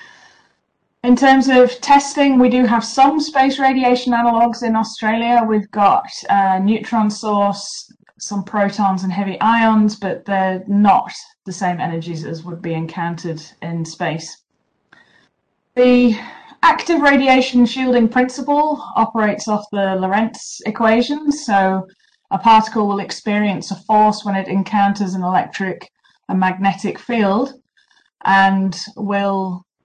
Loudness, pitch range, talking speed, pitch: -16 LUFS, 195-245 Hz, 125 wpm, 210 Hz